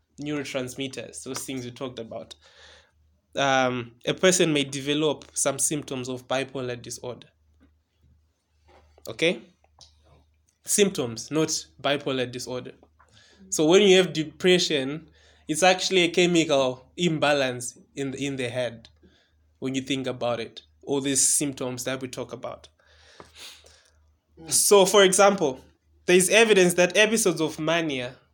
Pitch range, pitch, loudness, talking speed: 115-155 Hz, 135 Hz, -23 LUFS, 125 wpm